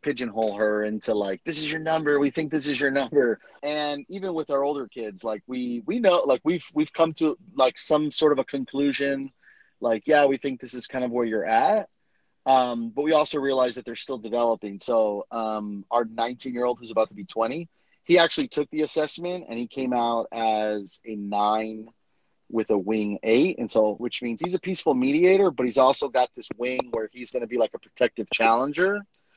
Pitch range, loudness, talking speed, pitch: 115-150 Hz, -25 LUFS, 215 wpm, 130 Hz